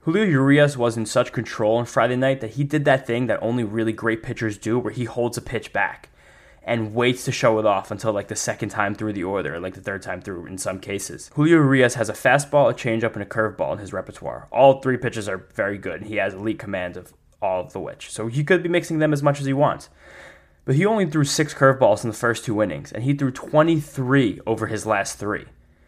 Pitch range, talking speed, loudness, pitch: 110-140 Hz, 250 wpm, -22 LUFS, 120 Hz